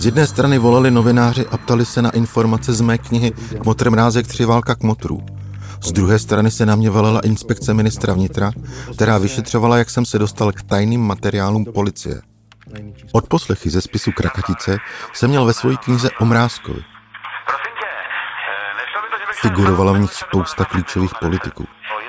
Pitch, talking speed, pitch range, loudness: 110 Hz, 155 wpm, 100-120 Hz, -17 LUFS